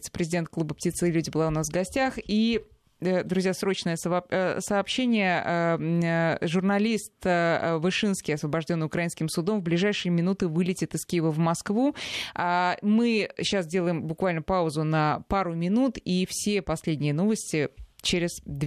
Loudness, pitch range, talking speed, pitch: -26 LUFS, 165-195 Hz, 130 wpm, 175 Hz